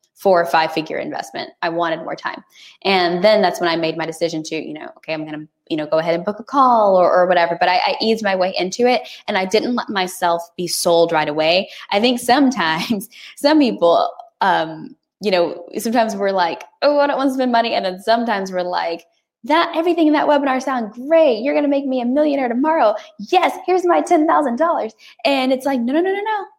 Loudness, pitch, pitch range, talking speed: -17 LUFS, 225 Hz, 175-285 Hz, 230 wpm